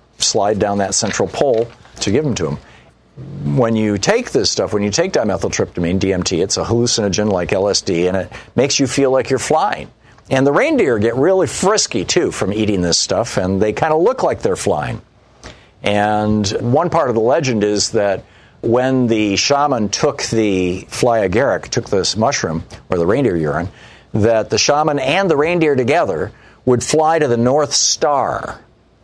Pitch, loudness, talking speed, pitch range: 105 Hz, -16 LUFS, 180 wpm, 100-125 Hz